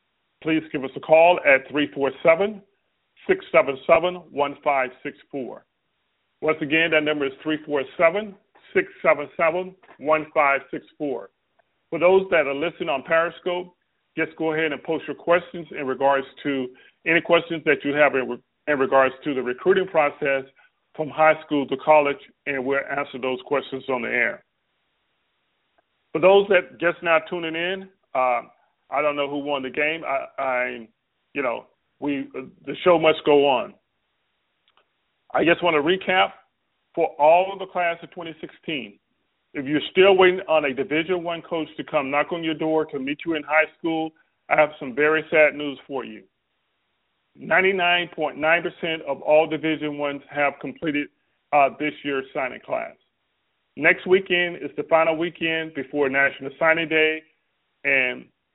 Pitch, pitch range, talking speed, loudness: 155 Hz, 140-170 Hz, 160 wpm, -22 LUFS